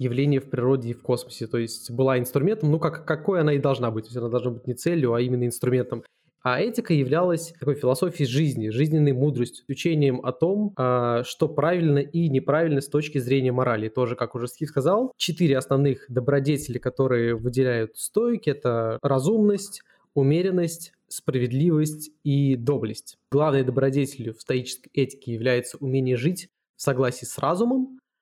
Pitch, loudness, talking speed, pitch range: 135 Hz, -24 LUFS, 160 wpm, 125-160 Hz